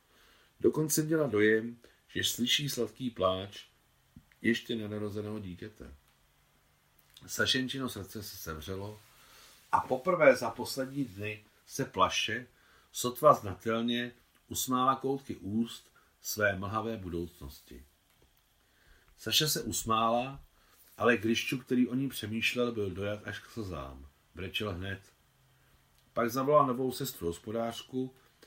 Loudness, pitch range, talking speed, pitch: -32 LUFS, 95-125 Hz, 105 wpm, 110 Hz